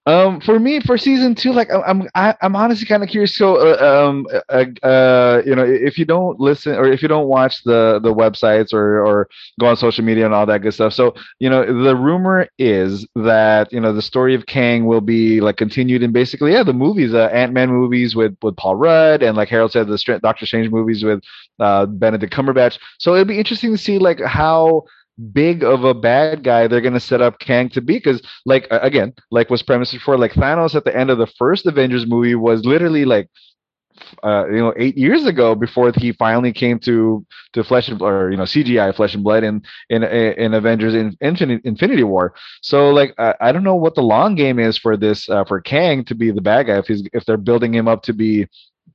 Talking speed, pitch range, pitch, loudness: 230 wpm, 110-145 Hz, 120 Hz, -15 LUFS